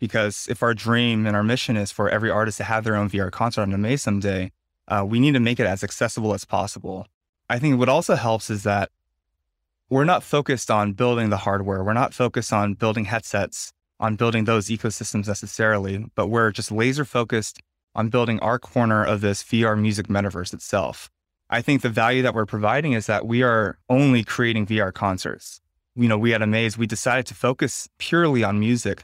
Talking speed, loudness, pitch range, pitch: 200 wpm, -22 LUFS, 100-120 Hz, 110 Hz